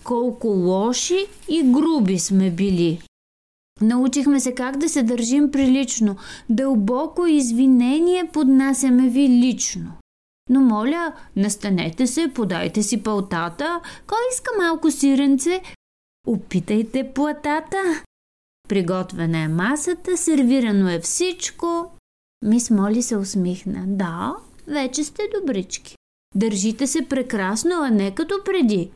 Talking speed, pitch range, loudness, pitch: 110 wpm, 200-300 Hz, -20 LUFS, 255 Hz